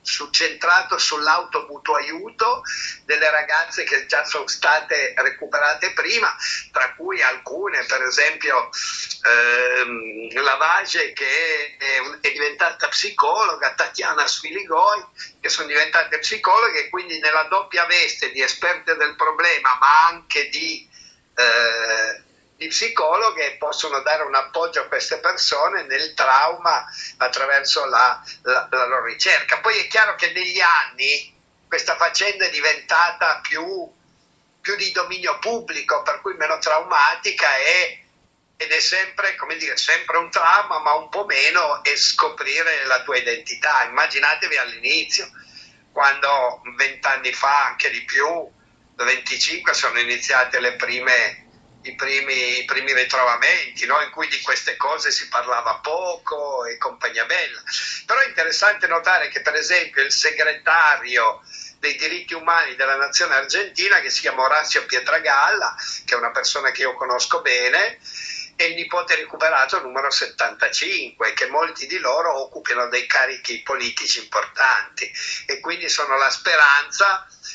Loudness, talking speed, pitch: -18 LUFS, 135 wpm, 180 Hz